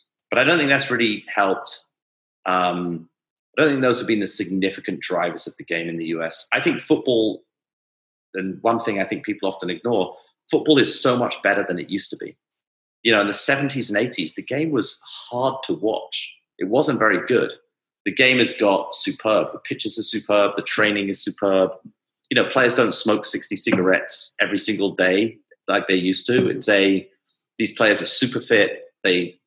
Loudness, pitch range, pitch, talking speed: -20 LUFS, 95-140 Hz, 100 Hz, 195 wpm